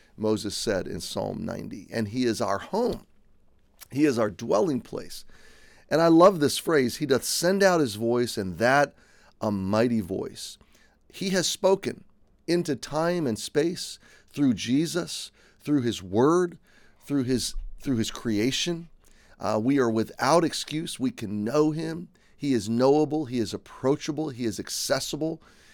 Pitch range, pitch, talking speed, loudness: 110-165 Hz, 135 Hz, 155 wpm, -26 LUFS